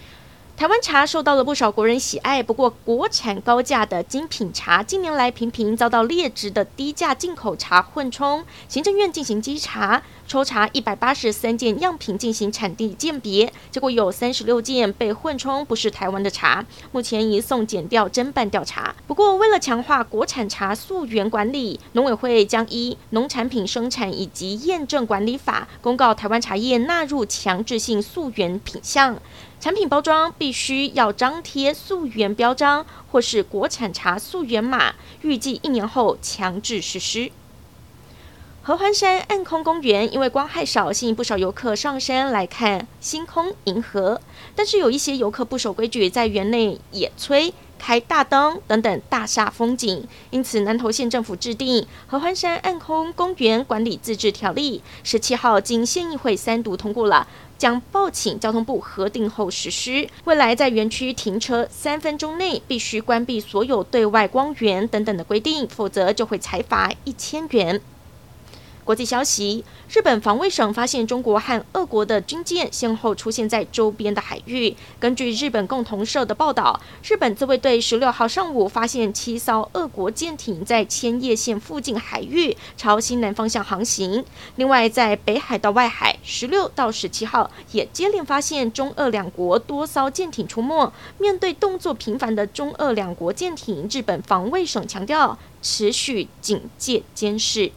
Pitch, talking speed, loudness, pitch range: 235 Hz, 260 characters per minute, -21 LUFS, 215-280 Hz